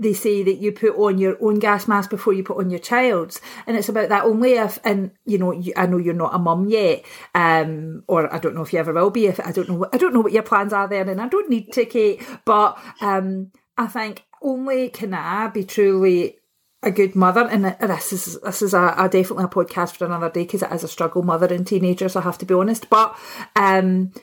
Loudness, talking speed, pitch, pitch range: -19 LUFS, 250 wpm, 195 Hz, 180-220 Hz